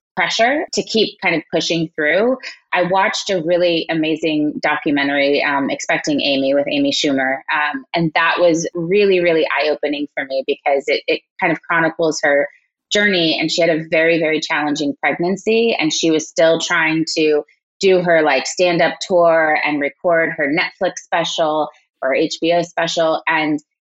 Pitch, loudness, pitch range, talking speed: 165 Hz, -16 LUFS, 150-180 Hz, 165 wpm